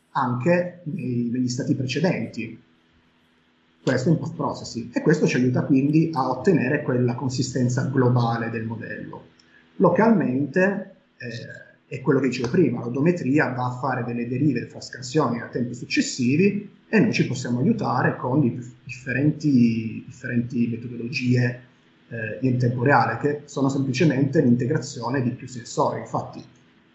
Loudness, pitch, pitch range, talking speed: -23 LUFS, 125 Hz, 120-145 Hz, 140 wpm